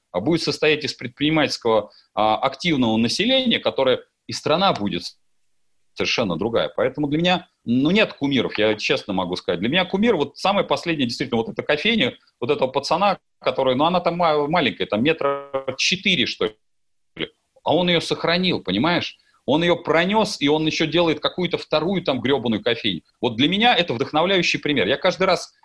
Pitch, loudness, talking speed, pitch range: 155 Hz, -20 LUFS, 170 wpm, 135-180 Hz